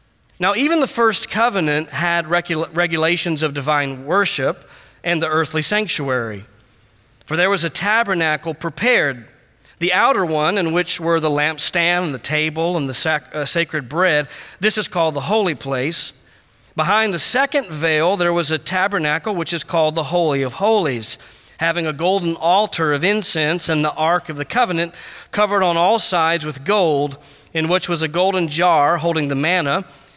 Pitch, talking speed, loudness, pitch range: 165 Hz, 170 wpm, -18 LUFS, 150-185 Hz